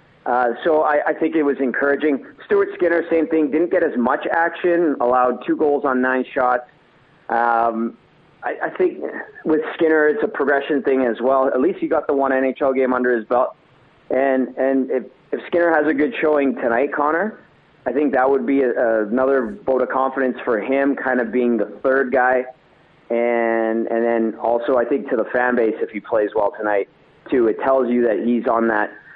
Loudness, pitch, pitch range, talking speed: -19 LUFS, 135 Hz, 125-150 Hz, 205 wpm